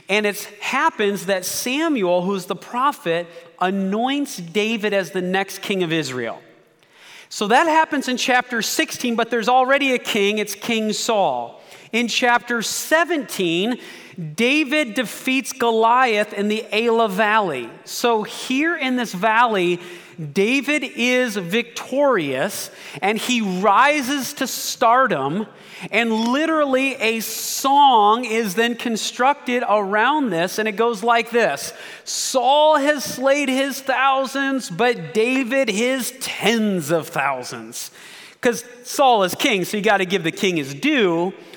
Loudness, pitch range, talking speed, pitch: -19 LUFS, 200-260 Hz, 130 wpm, 230 Hz